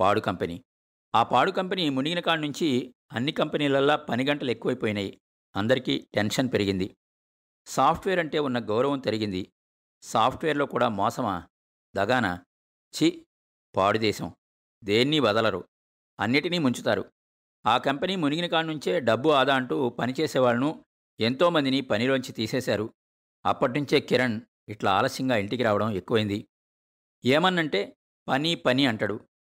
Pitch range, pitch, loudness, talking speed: 100-150 Hz, 125 Hz, -26 LUFS, 115 wpm